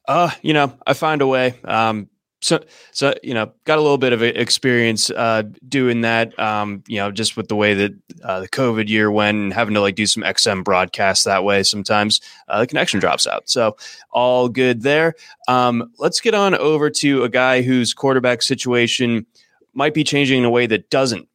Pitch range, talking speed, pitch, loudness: 110-135 Hz, 205 wpm, 120 Hz, -17 LUFS